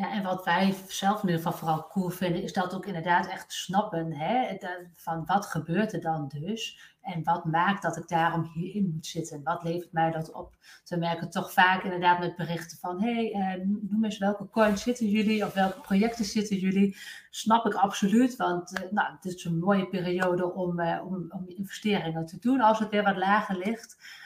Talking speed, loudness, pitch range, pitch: 200 wpm, -28 LUFS, 170-205 Hz, 185 Hz